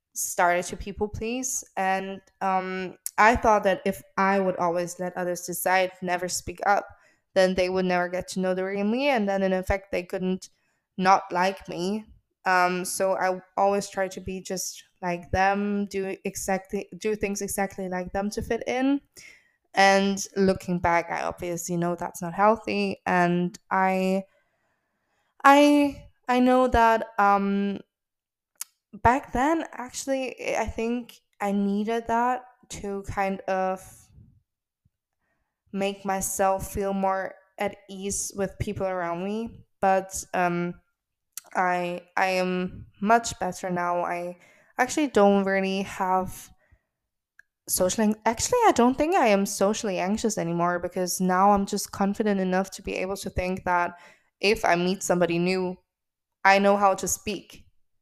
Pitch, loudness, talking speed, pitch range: 195 Hz, -25 LUFS, 145 wpm, 185-205 Hz